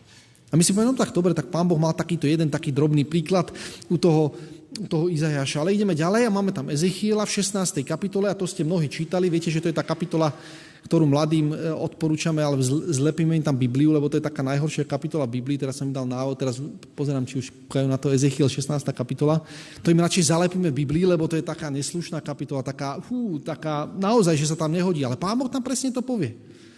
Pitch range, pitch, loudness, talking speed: 145-175 Hz, 160 Hz, -24 LUFS, 215 wpm